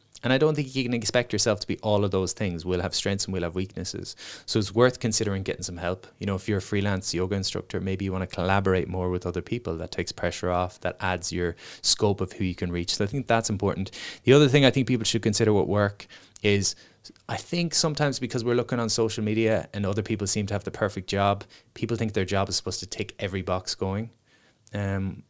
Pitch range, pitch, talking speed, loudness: 95-115 Hz, 100 Hz, 245 wpm, -26 LUFS